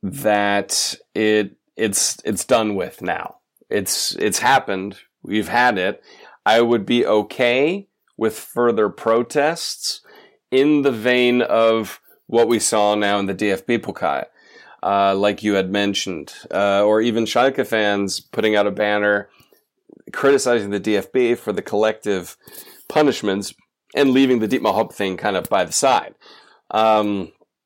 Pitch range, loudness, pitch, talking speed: 100-120 Hz, -19 LUFS, 105 Hz, 140 wpm